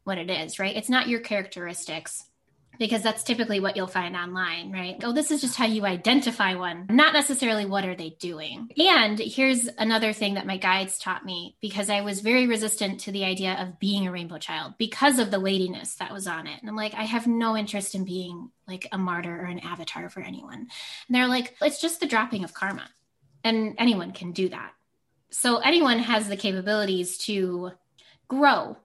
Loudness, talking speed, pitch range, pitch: -25 LUFS, 205 wpm, 185-235 Hz, 205 Hz